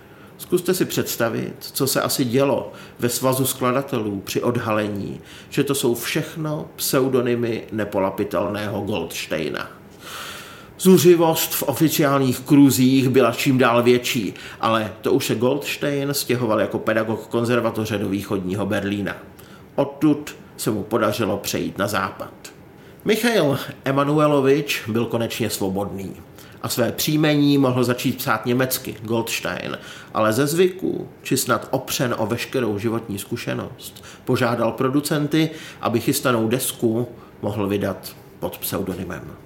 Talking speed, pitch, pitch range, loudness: 120 wpm, 120 Hz, 105-140 Hz, -21 LUFS